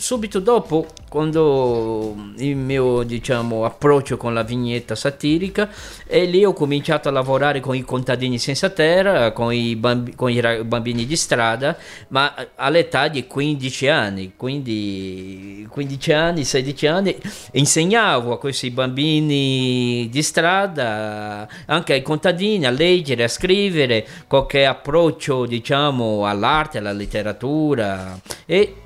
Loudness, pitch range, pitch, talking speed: -19 LUFS, 120-155 Hz, 135 Hz, 125 wpm